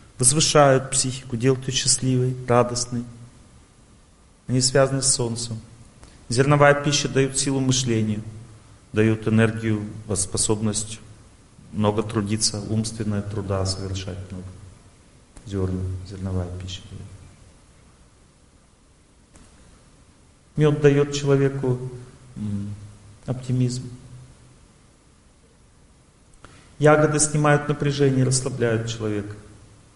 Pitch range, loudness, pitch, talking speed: 105-130 Hz, -22 LUFS, 115 Hz, 75 wpm